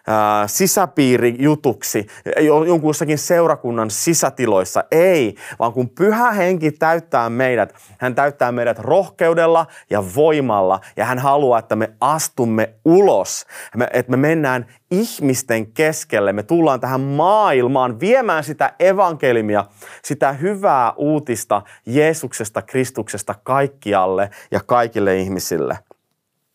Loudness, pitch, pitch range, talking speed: -17 LUFS, 130 Hz, 115-160 Hz, 100 wpm